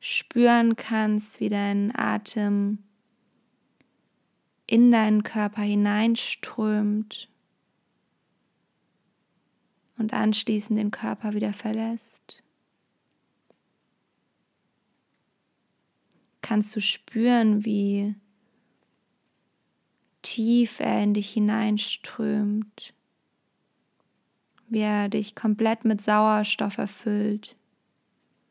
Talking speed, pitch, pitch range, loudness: 65 wpm, 215 Hz, 210-225 Hz, -25 LUFS